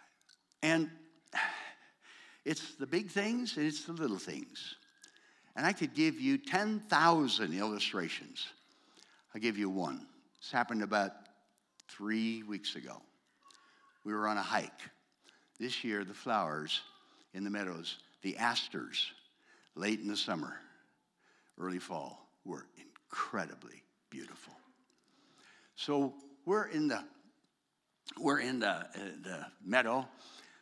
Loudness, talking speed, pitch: -36 LUFS, 120 wpm, 150 Hz